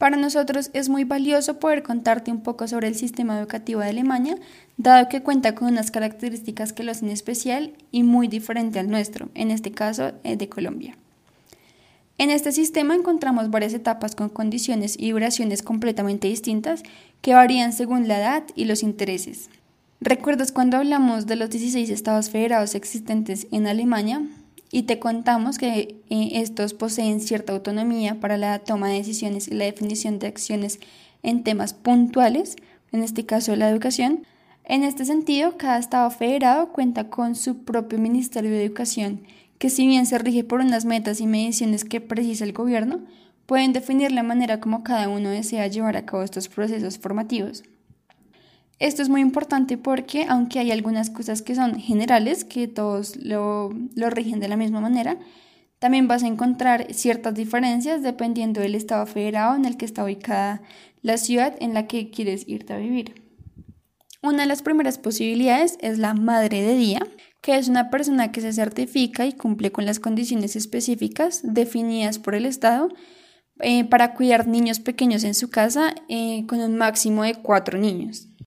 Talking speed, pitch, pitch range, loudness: 170 wpm, 230 Hz, 215-255 Hz, -22 LUFS